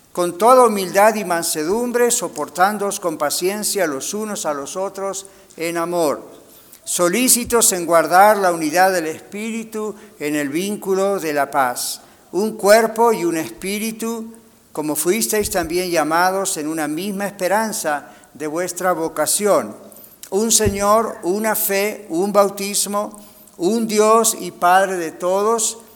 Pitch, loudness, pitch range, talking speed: 195 Hz, -18 LUFS, 170-215 Hz, 130 wpm